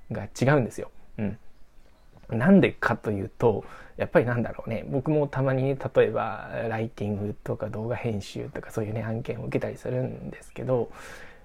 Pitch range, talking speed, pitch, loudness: 110-135 Hz, 355 characters per minute, 115 Hz, -27 LUFS